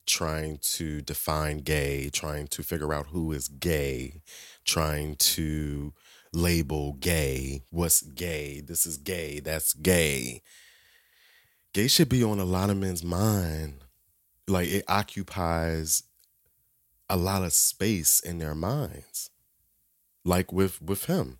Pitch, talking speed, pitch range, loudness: 80 Hz, 125 wpm, 75-90 Hz, -27 LUFS